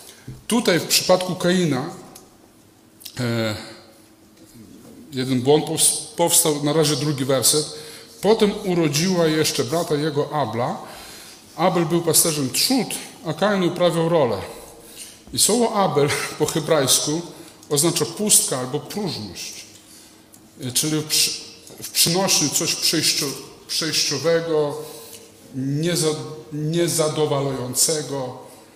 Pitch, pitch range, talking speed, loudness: 155 Hz, 145-170 Hz, 90 wpm, -20 LUFS